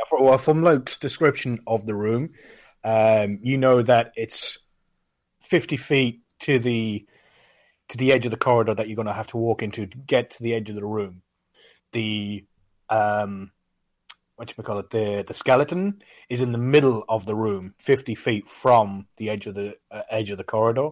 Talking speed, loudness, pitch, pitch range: 190 wpm, -23 LUFS, 110 Hz, 105-125 Hz